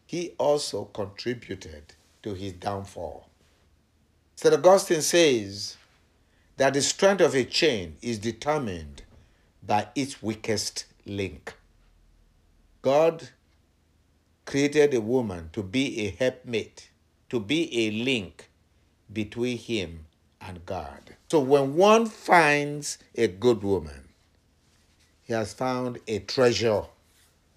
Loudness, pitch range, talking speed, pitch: -25 LUFS, 80-135 Hz, 105 wpm, 105 Hz